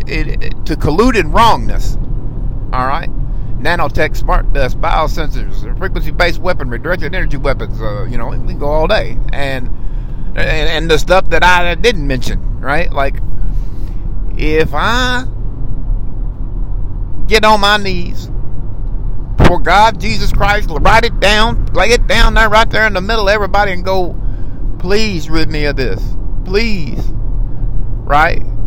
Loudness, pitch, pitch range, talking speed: -15 LUFS, 125 Hz, 110-170 Hz, 140 wpm